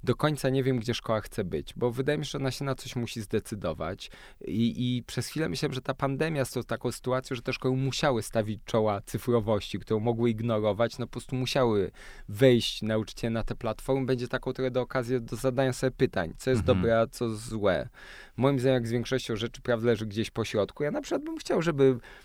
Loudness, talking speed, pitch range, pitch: -29 LUFS, 220 wpm, 115-130 Hz, 125 Hz